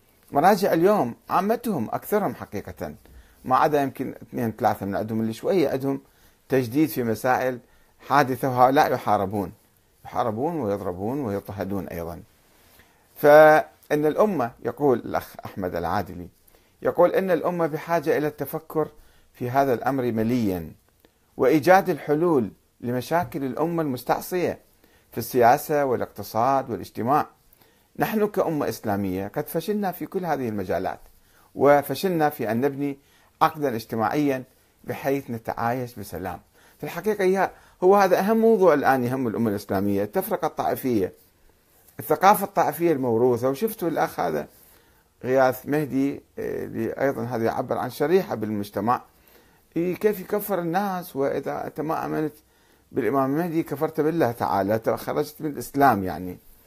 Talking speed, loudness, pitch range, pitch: 120 wpm, -24 LUFS, 110-155 Hz, 135 Hz